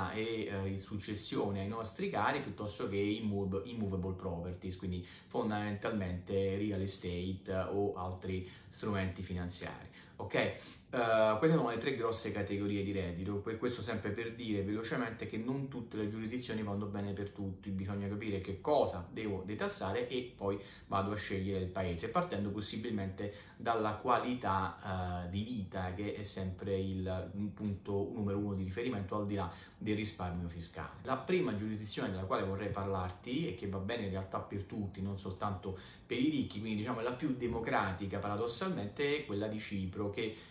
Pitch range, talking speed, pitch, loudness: 95-110 Hz, 165 wpm, 100 Hz, -38 LUFS